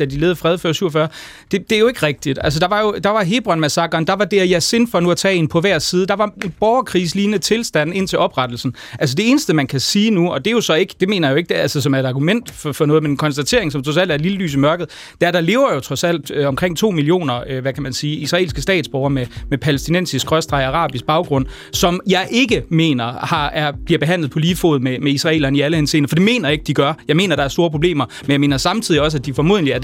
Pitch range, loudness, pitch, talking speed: 145-185 Hz, -16 LUFS, 160 Hz, 290 wpm